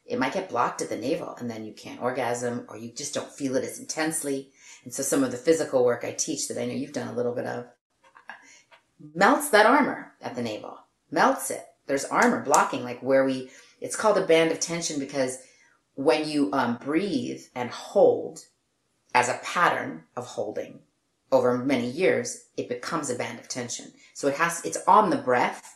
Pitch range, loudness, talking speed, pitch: 120-155 Hz, -25 LUFS, 200 wpm, 135 Hz